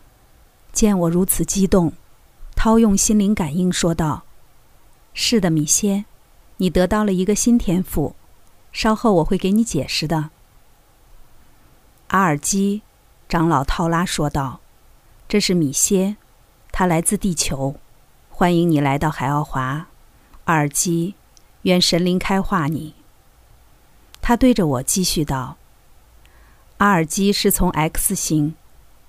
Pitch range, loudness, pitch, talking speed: 145-195 Hz, -19 LUFS, 170 Hz, 175 characters per minute